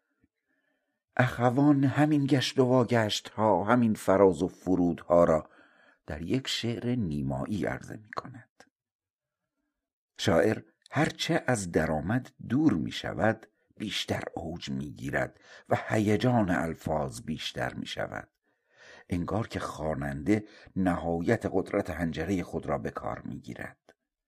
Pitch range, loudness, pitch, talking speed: 85-125 Hz, -29 LUFS, 105 Hz, 120 wpm